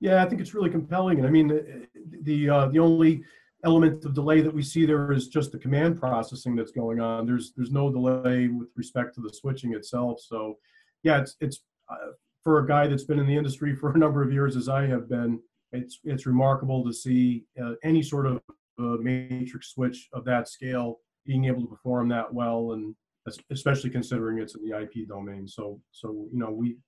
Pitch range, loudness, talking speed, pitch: 120-150 Hz, -26 LUFS, 210 wpm, 130 Hz